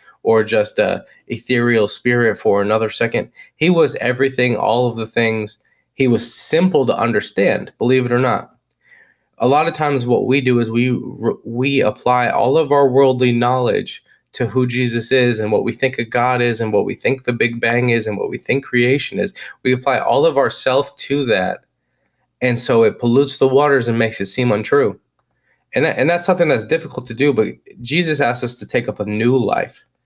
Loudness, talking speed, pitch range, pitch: -17 LUFS, 205 wpm, 115-135 Hz, 125 Hz